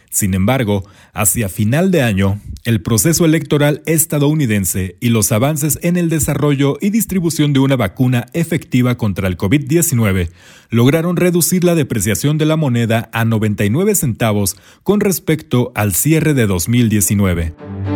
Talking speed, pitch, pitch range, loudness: 135 wpm, 125 Hz, 105-155 Hz, -15 LUFS